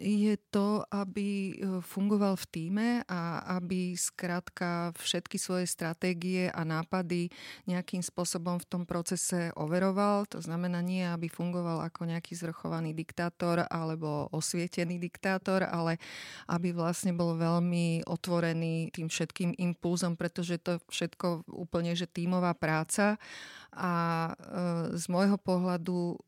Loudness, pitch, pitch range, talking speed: -33 LUFS, 175 Hz, 170-185 Hz, 125 wpm